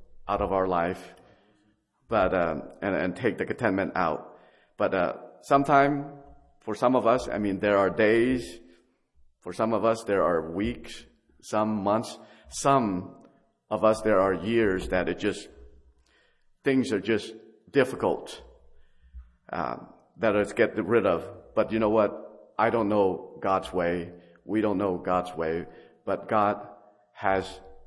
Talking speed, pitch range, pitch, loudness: 150 wpm, 90-110 Hz, 105 Hz, -26 LUFS